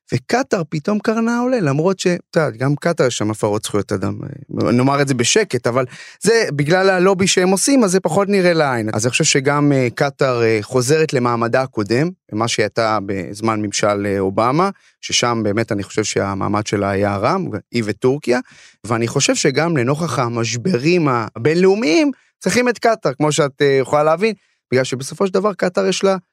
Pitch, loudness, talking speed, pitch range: 145 Hz, -17 LUFS, 175 wpm, 115-185 Hz